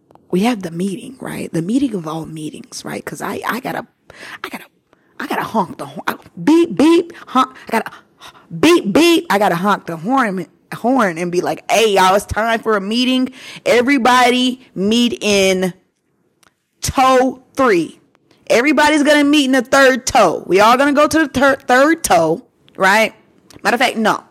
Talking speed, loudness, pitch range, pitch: 180 wpm, -15 LUFS, 195-285 Hz, 250 Hz